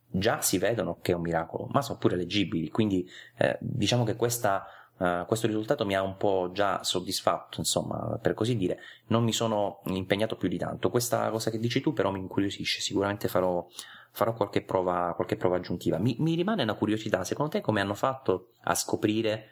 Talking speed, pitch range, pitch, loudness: 195 wpm, 90-115 Hz, 100 Hz, -29 LUFS